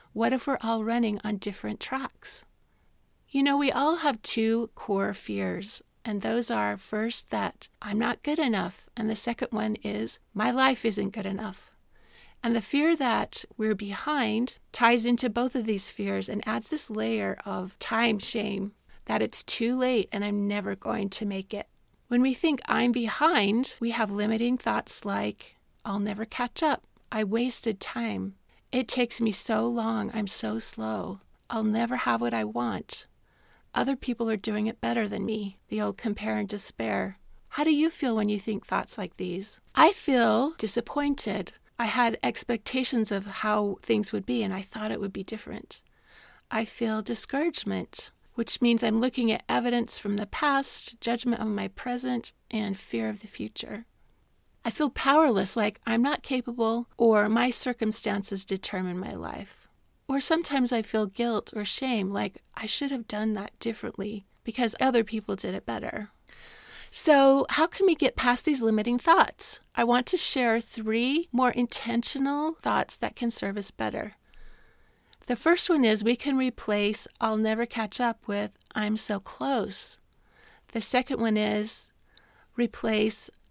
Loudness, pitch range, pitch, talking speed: -28 LUFS, 210-250 Hz, 225 Hz, 165 wpm